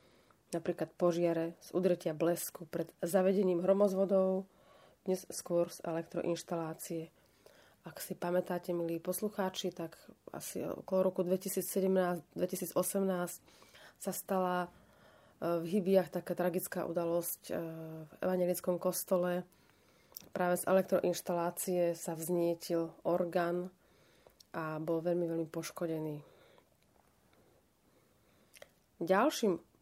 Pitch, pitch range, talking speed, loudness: 180 Hz, 170-185 Hz, 90 wpm, -35 LUFS